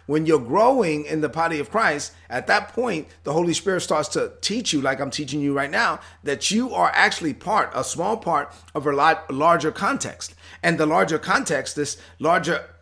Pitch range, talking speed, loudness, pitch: 145-190 Hz, 200 wpm, -22 LUFS, 155 Hz